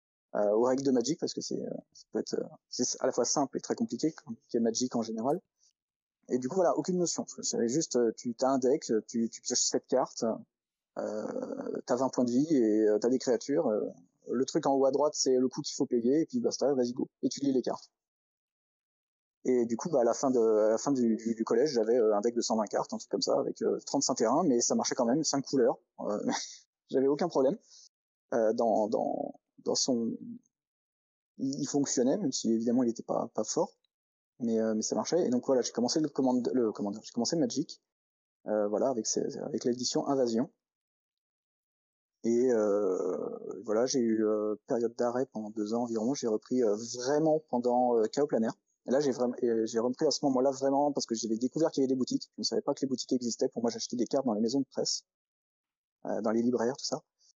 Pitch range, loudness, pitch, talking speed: 115-140 Hz, -30 LUFS, 125 Hz, 230 wpm